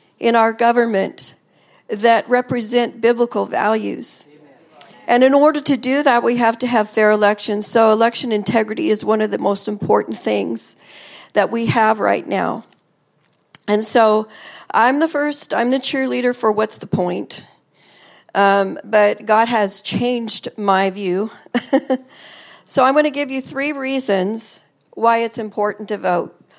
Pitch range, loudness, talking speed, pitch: 210-250 Hz, -17 LUFS, 150 wpm, 225 Hz